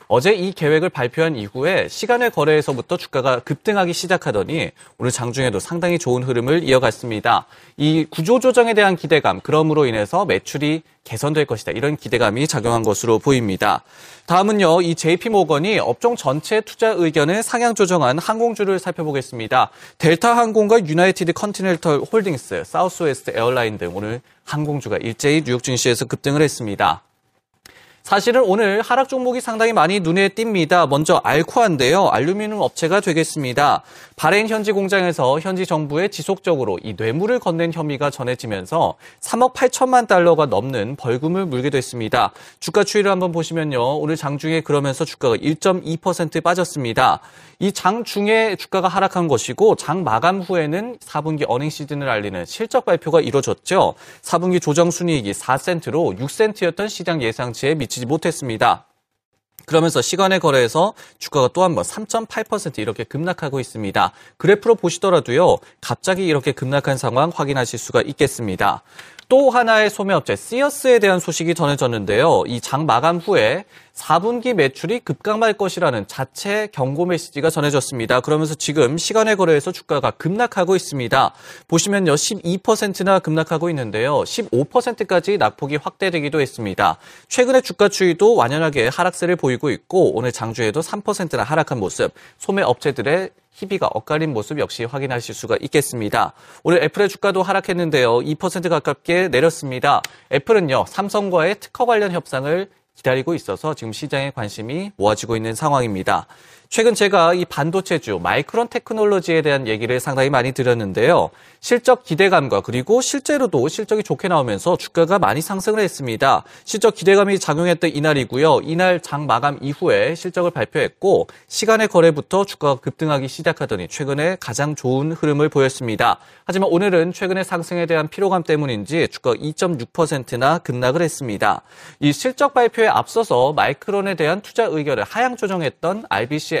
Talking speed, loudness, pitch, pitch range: 370 characters per minute, -18 LUFS, 165 Hz, 140-195 Hz